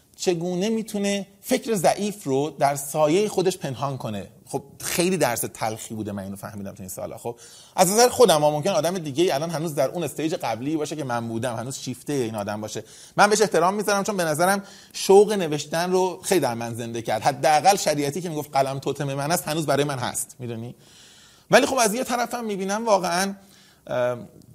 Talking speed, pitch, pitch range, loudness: 195 wpm, 155 Hz, 130-195 Hz, -23 LUFS